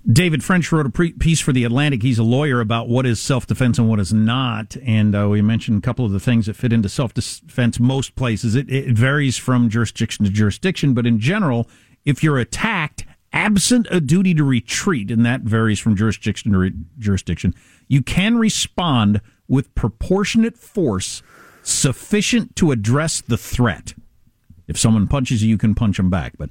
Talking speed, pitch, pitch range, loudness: 185 wpm, 120 Hz, 110-145 Hz, -18 LUFS